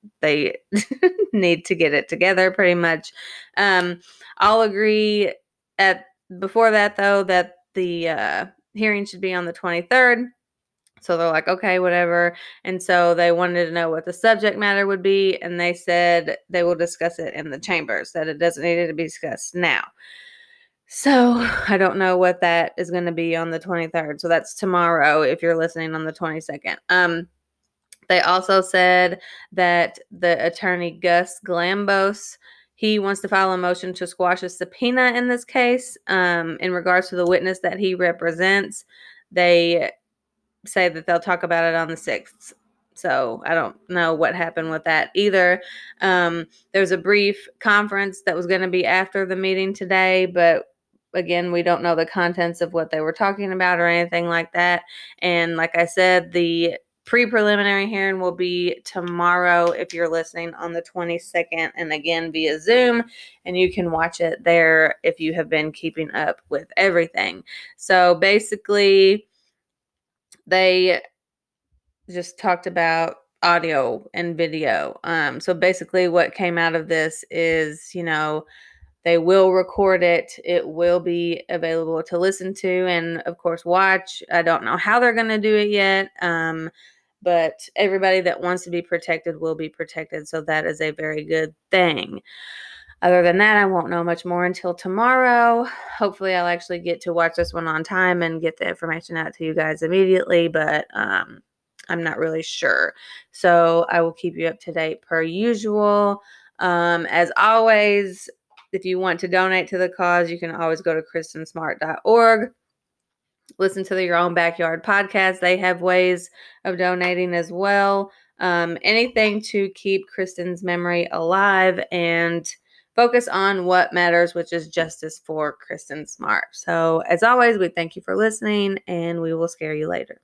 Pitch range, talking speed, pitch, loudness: 170-195 Hz, 170 wpm, 180 Hz, -20 LUFS